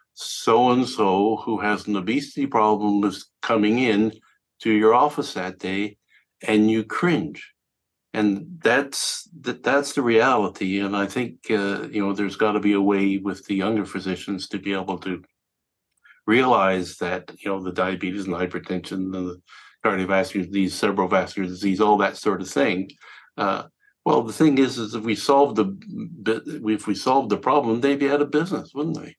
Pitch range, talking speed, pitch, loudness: 95-125 Hz, 175 wpm, 105 Hz, -22 LUFS